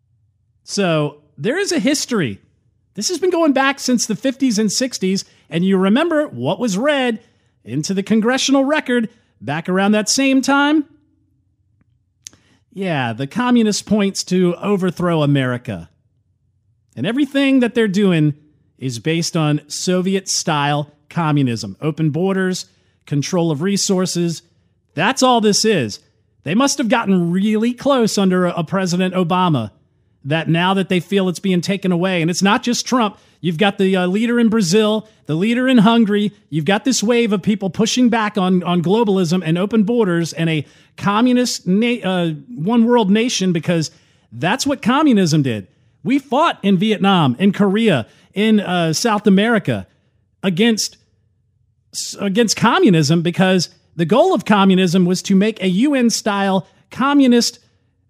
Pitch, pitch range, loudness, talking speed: 190 Hz, 150-225 Hz, -17 LUFS, 150 wpm